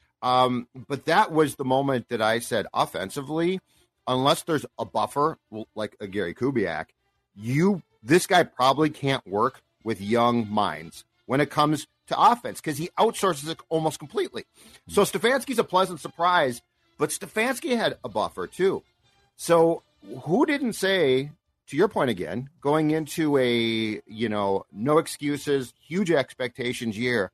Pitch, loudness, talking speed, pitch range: 145 Hz, -25 LUFS, 145 wpm, 120-170 Hz